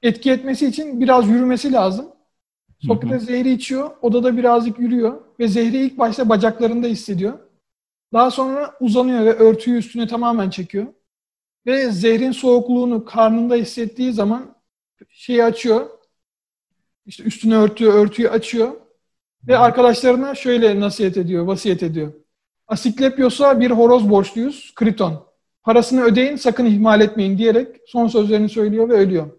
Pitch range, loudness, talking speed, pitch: 220-250 Hz, -16 LUFS, 125 wpm, 235 Hz